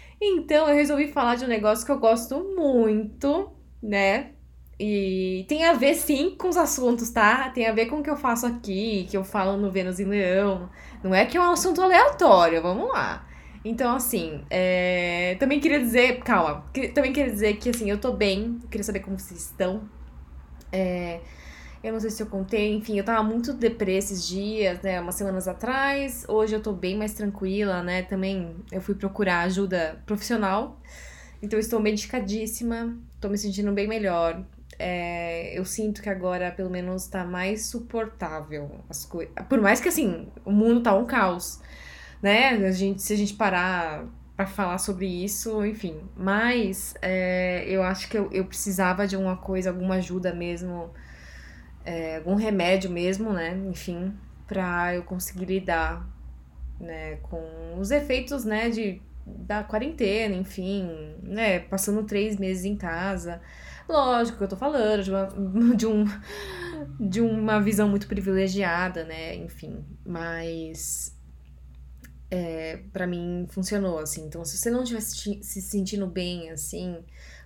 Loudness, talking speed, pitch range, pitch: -25 LUFS, 165 wpm, 180-220 Hz, 195 Hz